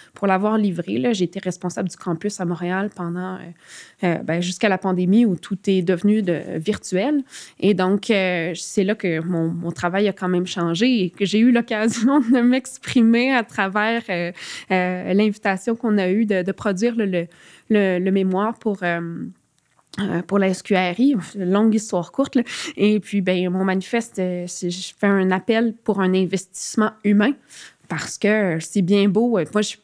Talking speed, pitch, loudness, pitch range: 180 wpm, 195 Hz, -20 LUFS, 180-215 Hz